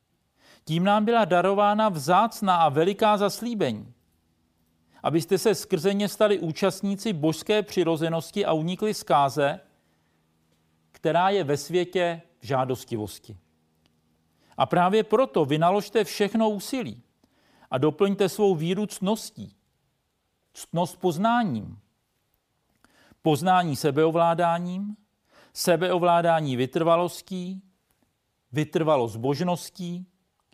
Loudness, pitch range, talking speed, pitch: -24 LUFS, 140-200 Hz, 85 wpm, 175 Hz